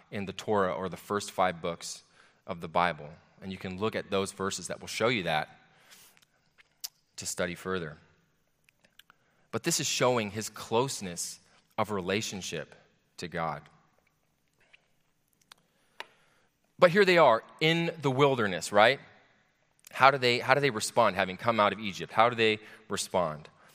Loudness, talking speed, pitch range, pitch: -28 LUFS, 150 wpm, 95-130 Hz, 105 Hz